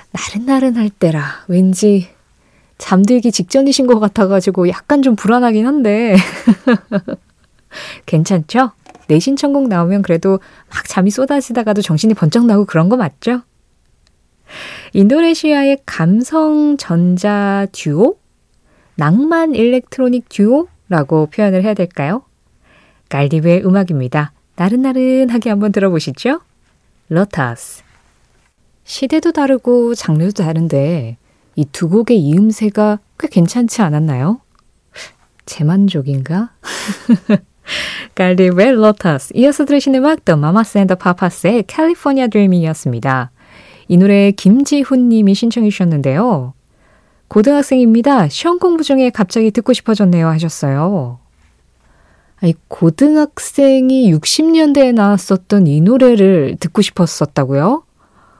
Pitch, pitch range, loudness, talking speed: 205 Hz, 170-250 Hz, -13 LUFS, 265 characters per minute